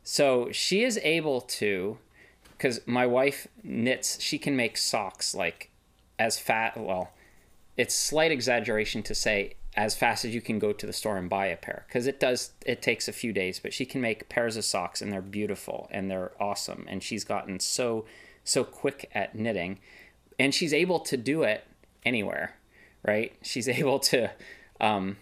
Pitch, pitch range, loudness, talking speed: 110 Hz, 100-125 Hz, -28 LUFS, 180 wpm